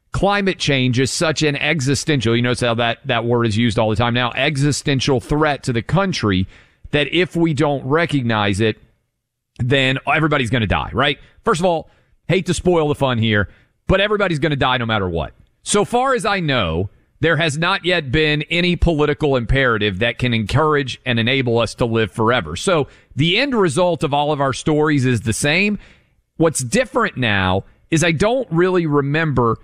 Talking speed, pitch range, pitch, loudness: 190 wpm, 120-165 Hz, 140 Hz, -17 LUFS